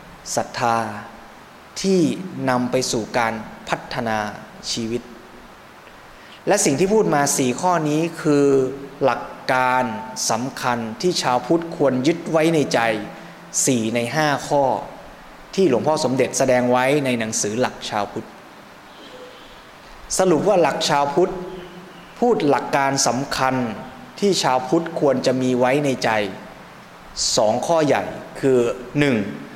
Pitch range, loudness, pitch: 125-165 Hz, -20 LUFS, 135 Hz